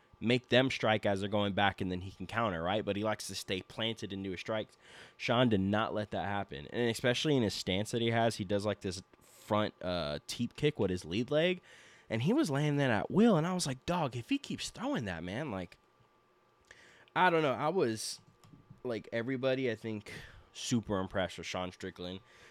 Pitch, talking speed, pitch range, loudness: 110 Hz, 220 wpm, 100-125 Hz, -33 LUFS